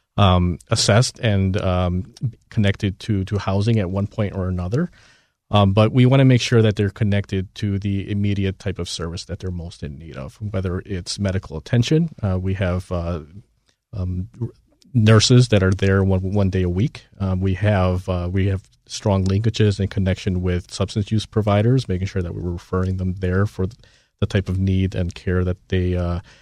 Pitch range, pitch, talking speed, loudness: 90-110 Hz, 95 Hz, 195 wpm, -20 LUFS